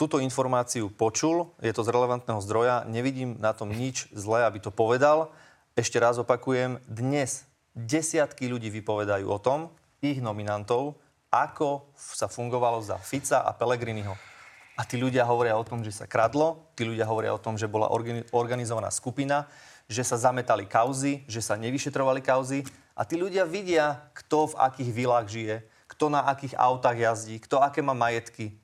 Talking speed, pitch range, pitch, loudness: 165 wpm, 115-140 Hz, 125 Hz, -27 LUFS